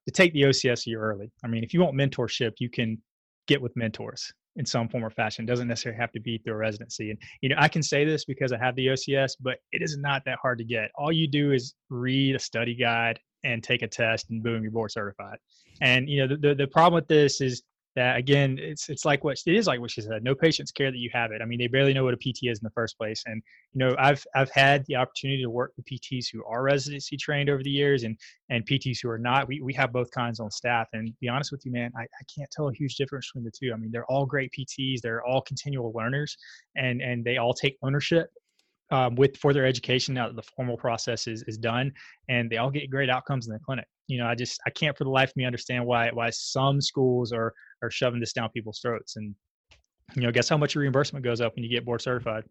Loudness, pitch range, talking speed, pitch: -27 LUFS, 115-140 Hz, 270 wpm, 125 Hz